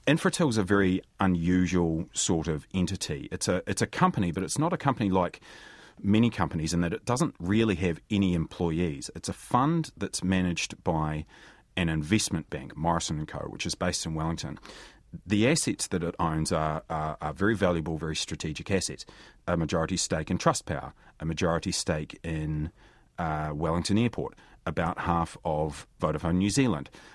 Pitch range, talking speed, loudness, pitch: 80-105 Hz, 170 wpm, -29 LUFS, 90 Hz